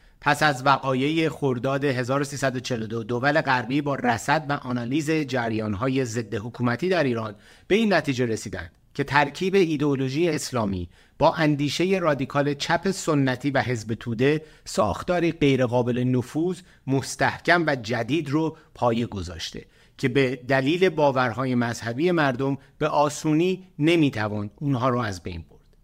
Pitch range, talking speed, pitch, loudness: 120-155 Hz, 130 wpm, 135 Hz, -24 LUFS